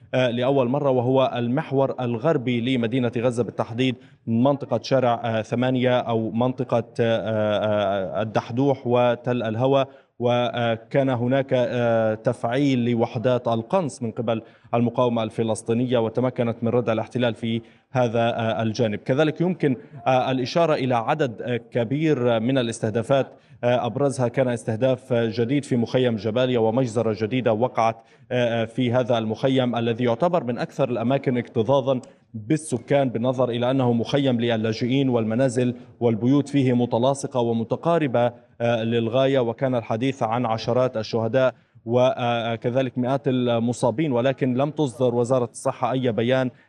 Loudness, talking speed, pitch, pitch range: -23 LUFS, 110 wpm, 125 Hz, 115-130 Hz